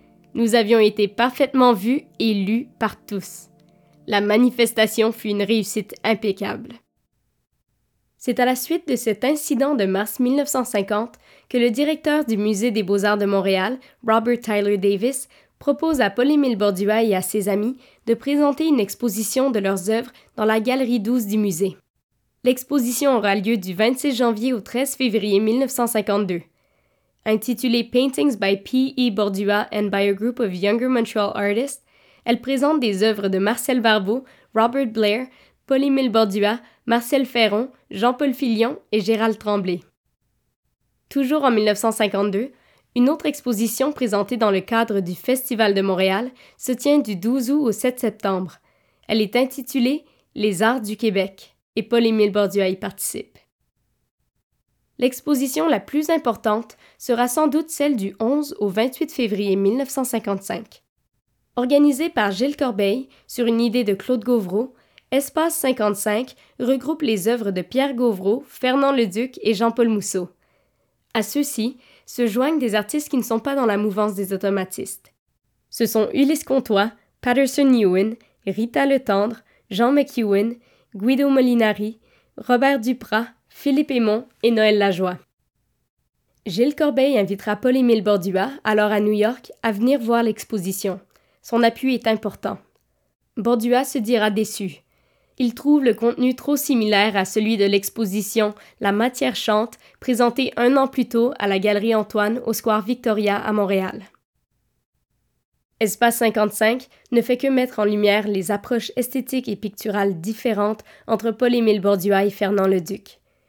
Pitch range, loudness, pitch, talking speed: 210-255 Hz, -20 LUFS, 230 Hz, 145 wpm